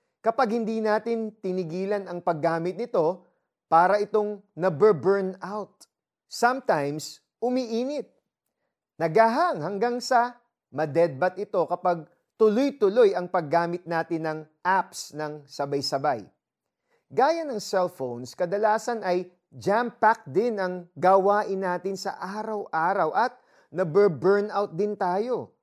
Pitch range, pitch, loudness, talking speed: 175-220 Hz, 195 Hz, -25 LUFS, 110 wpm